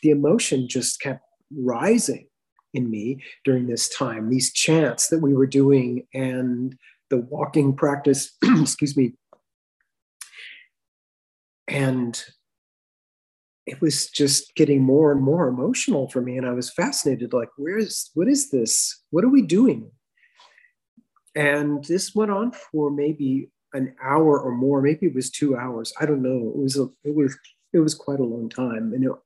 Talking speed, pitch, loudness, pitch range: 160 wpm, 140 Hz, -22 LUFS, 130-155 Hz